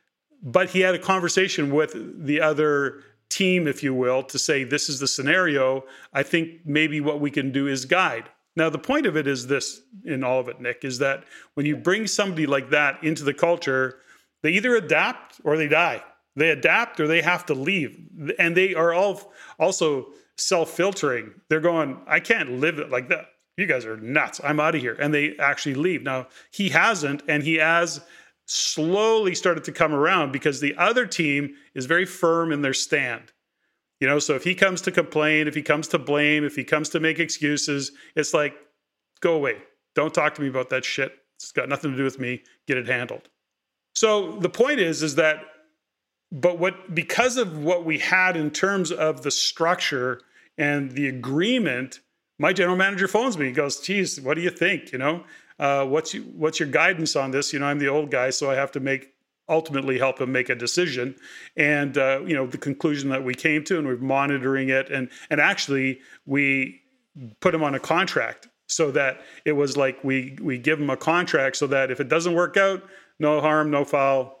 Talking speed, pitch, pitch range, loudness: 205 wpm, 150 Hz, 135-175 Hz, -23 LUFS